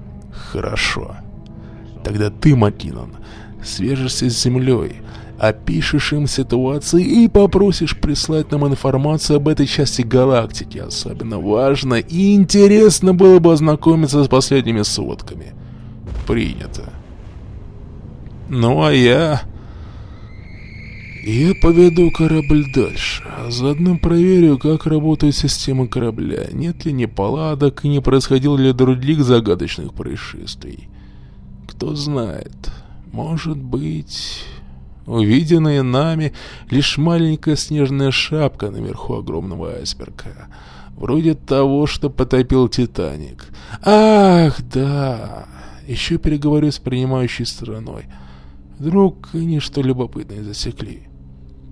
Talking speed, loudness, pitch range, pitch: 95 wpm, -16 LUFS, 110-155 Hz, 130 Hz